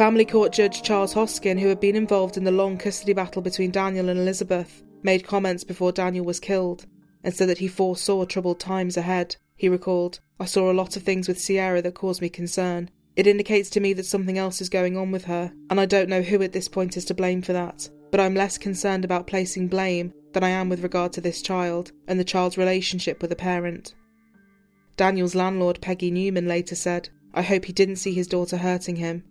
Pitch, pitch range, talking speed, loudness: 185 Hz, 180-195 Hz, 220 wpm, -24 LUFS